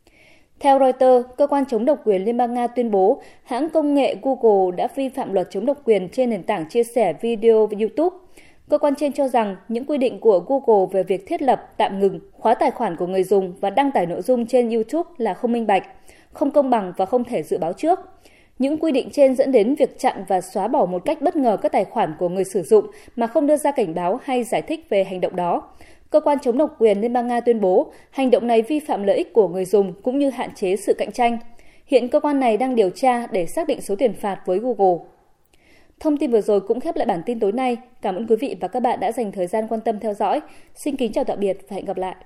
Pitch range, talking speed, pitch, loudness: 200-285 Hz, 260 wpm, 240 Hz, -20 LUFS